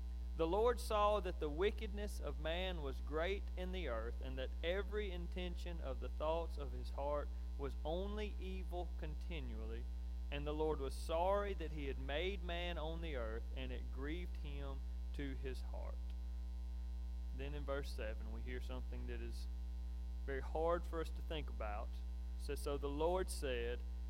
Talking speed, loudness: 170 wpm, -44 LUFS